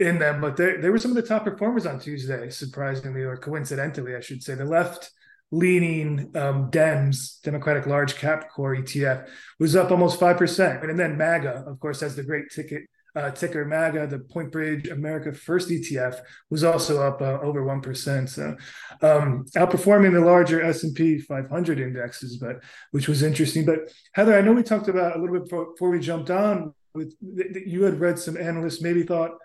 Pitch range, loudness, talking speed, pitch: 140-175 Hz, -23 LUFS, 190 wpm, 155 Hz